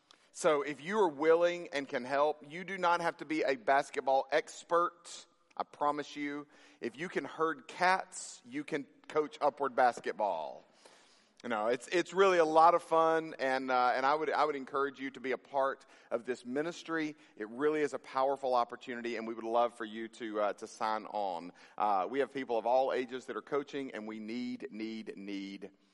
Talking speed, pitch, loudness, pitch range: 200 wpm, 140 Hz, -33 LUFS, 120-160 Hz